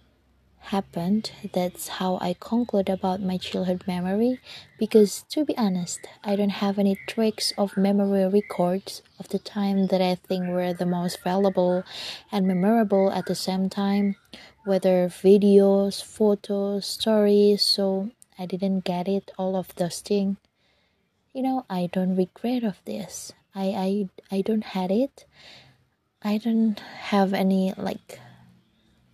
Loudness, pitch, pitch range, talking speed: -24 LUFS, 195 Hz, 185-205 Hz, 140 wpm